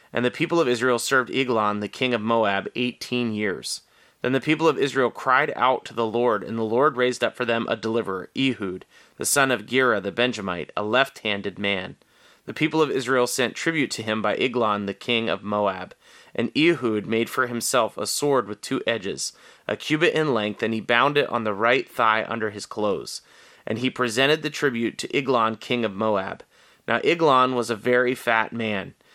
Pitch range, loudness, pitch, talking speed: 110-130 Hz, -23 LUFS, 120 Hz, 205 wpm